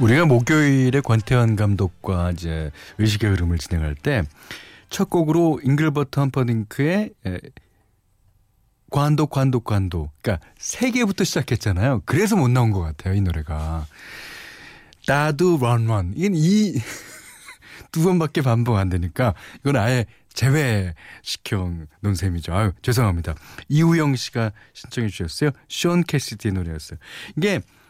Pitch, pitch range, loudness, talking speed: 115 Hz, 95-145 Hz, -21 LUFS, 285 characters per minute